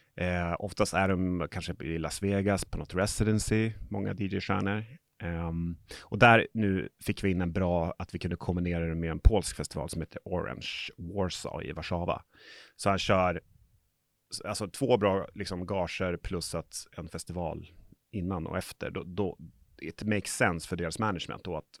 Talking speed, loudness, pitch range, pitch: 170 wpm, -31 LUFS, 85-100 Hz, 95 Hz